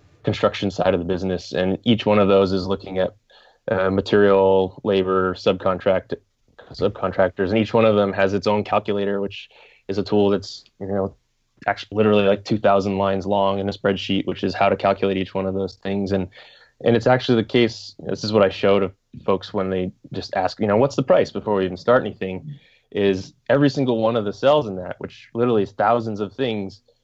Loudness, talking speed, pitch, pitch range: -21 LUFS, 215 wpm, 100 Hz, 95-105 Hz